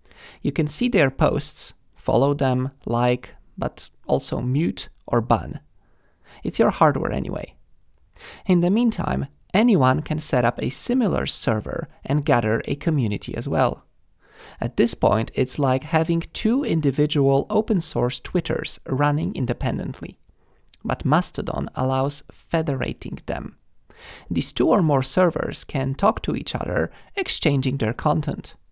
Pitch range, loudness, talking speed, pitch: 130-170 Hz, -22 LUFS, 135 wpm, 145 Hz